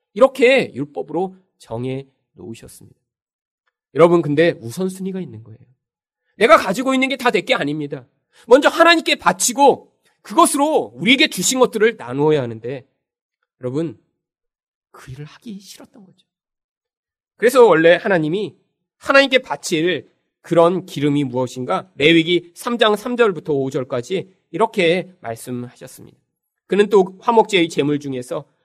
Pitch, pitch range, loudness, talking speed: 180 Hz, 145-240 Hz, -16 LUFS, 300 characters per minute